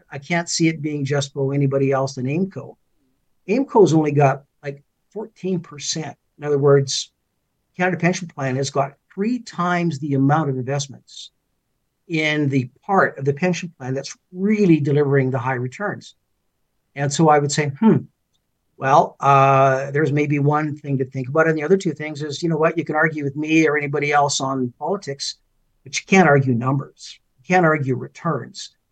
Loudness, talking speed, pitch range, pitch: -20 LUFS, 180 wpm, 135-165 Hz, 145 Hz